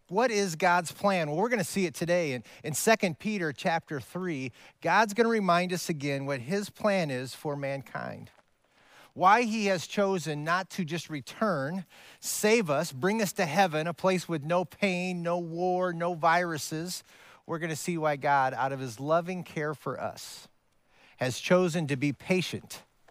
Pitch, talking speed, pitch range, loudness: 175 Hz, 180 wpm, 150-190 Hz, -29 LUFS